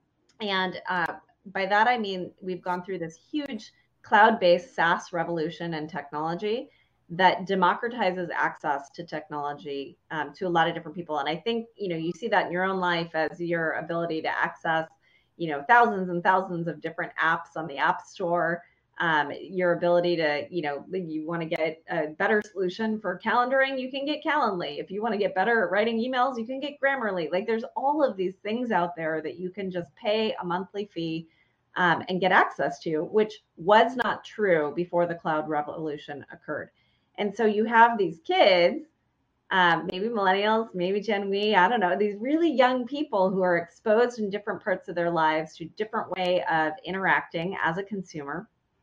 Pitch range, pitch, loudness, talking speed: 165-215 Hz, 180 Hz, -26 LUFS, 190 wpm